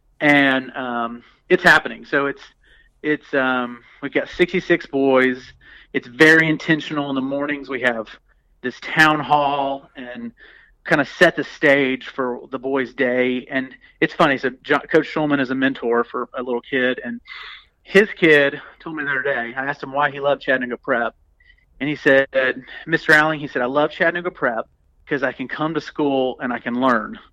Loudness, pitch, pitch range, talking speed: -19 LUFS, 140 Hz, 125-150 Hz, 185 wpm